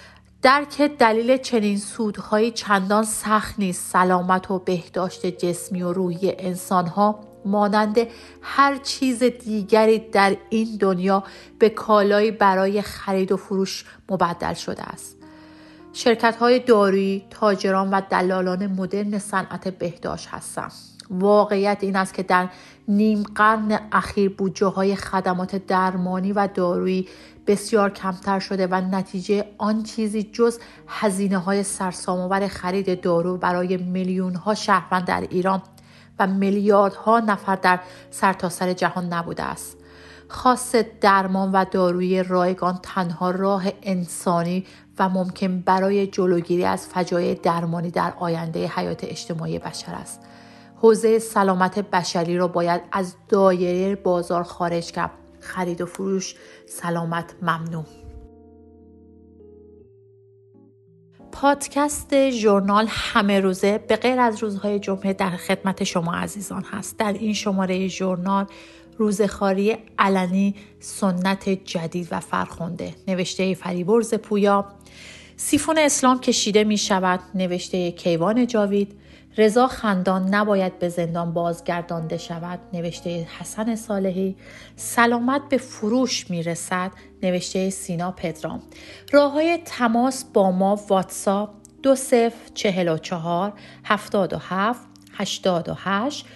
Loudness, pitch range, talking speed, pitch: -22 LUFS, 180-210 Hz, 115 wpm, 195 Hz